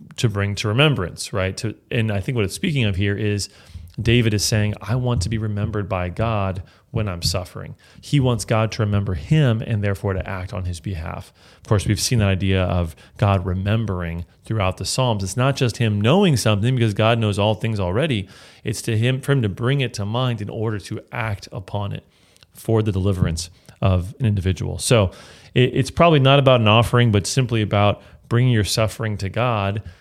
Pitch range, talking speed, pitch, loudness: 95-120 Hz, 205 wpm, 110 Hz, -20 LUFS